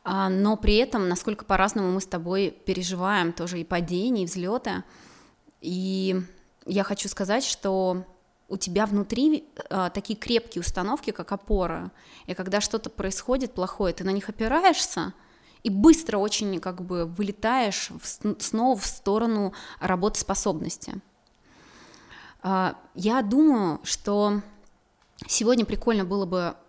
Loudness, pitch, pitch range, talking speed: -25 LUFS, 200 Hz, 185-220 Hz, 125 wpm